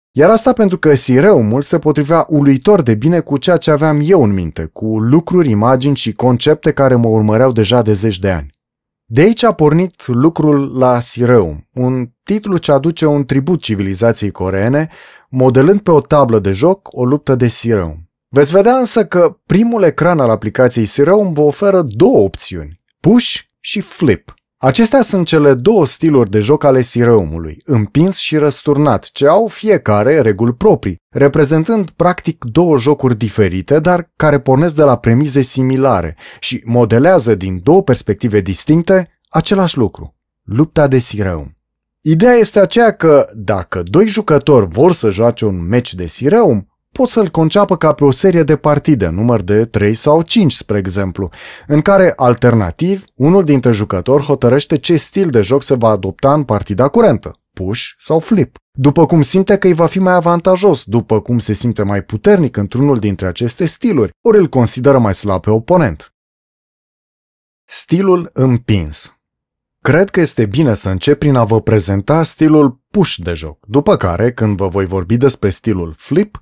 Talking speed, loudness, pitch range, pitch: 165 wpm, -12 LUFS, 110-165 Hz, 135 Hz